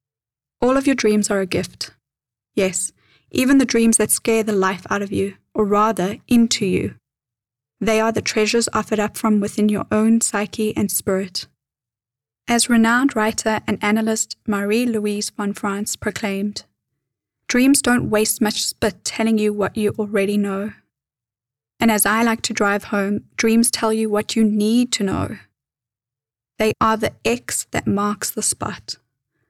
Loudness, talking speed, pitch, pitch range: -19 LUFS, 160 wpm, 210 Hz, 195-225 Hz